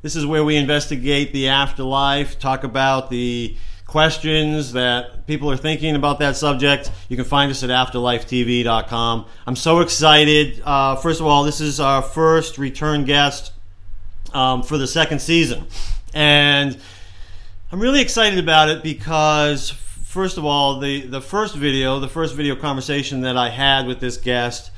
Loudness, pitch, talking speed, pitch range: -17 LUFS, 140 Hz, 160 wpm, 125-150 Hz